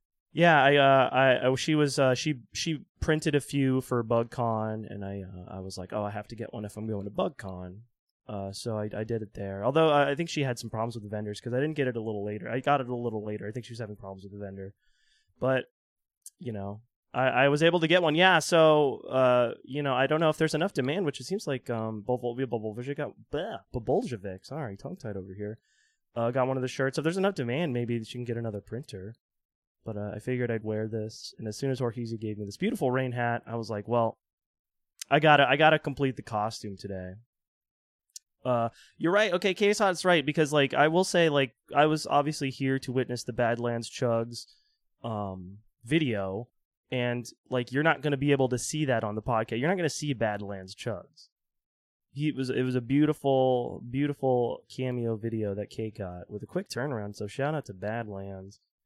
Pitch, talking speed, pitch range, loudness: 125 Hz, 225 wpm, 110-145 Hz, -28 LUFS